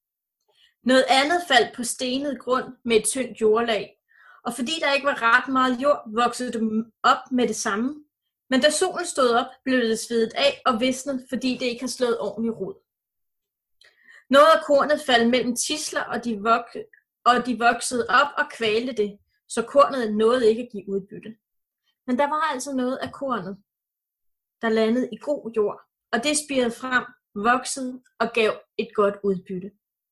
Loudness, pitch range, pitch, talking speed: -22 LUFS, 225-275 Hz, 245 Hz, 175 wpm